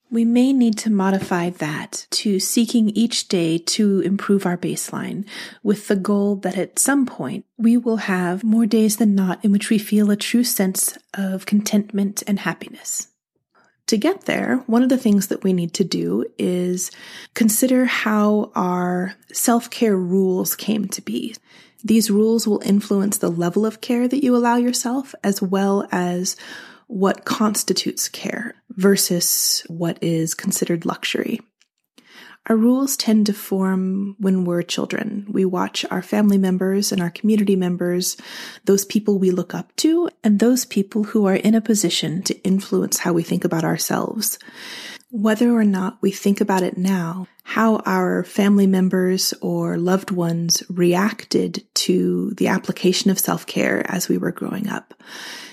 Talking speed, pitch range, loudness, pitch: 160 wpm, 185-225 Hz, -19 LUFS, 200 Hz